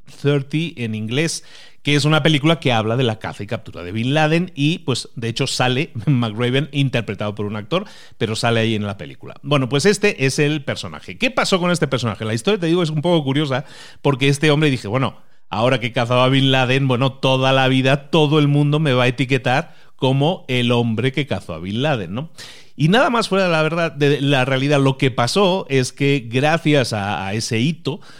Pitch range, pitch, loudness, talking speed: 120-155 Hz, 135 Hz, -18 LUFS, 220 wpm